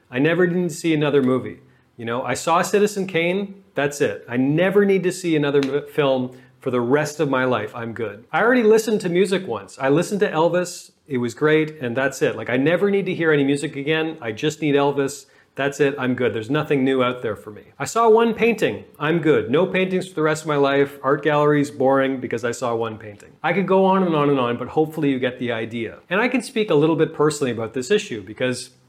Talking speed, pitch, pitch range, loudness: 245 wpm, 150 Hz, 130-180 Hz, -20 LUFS